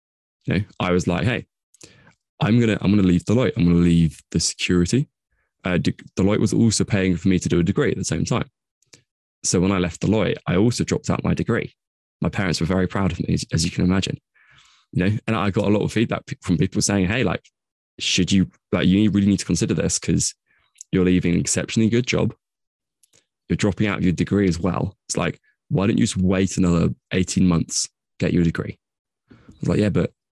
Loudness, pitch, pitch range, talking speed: -21 LUFS, 95 Hz, 90-100 Hz, 220 wpm